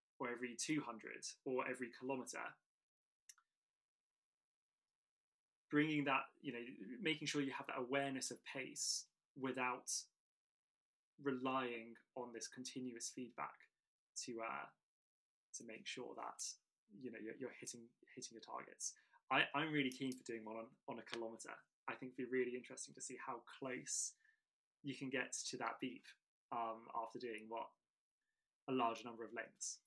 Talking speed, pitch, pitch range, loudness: 150 wpm, 125 Hz, 120-135 Hz, -46 LUFS